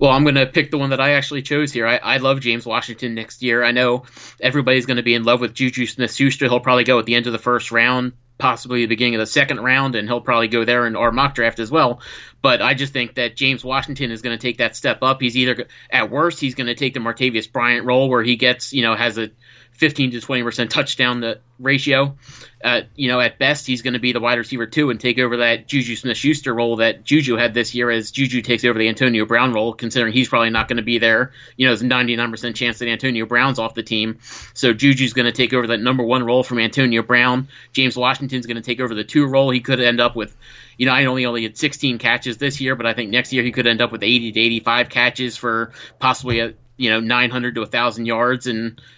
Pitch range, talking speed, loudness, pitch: 115-130 Hz, 260 wpm, -18 LUFS, 125 Hz